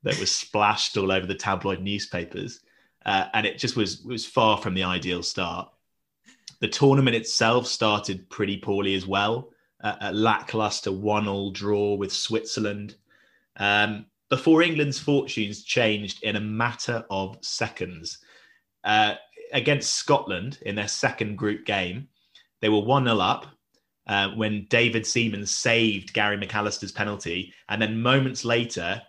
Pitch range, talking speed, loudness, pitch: 100-115 Hz, 140 wpm, -24 LUFS, 105 Hz